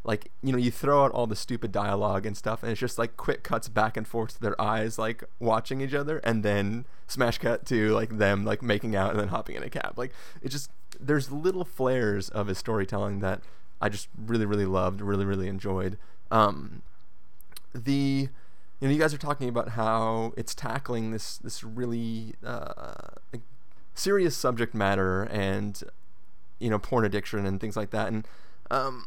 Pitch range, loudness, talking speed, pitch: 100-125 Hz, -29 LUFS, 190 wpm, 110 Hz